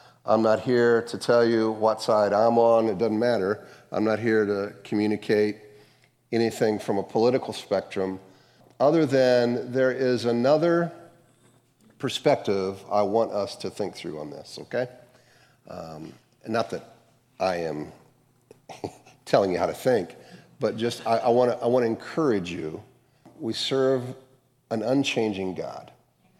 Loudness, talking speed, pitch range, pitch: -25 LUFS, 145 wpm, 110-125 Hz, 115 Hz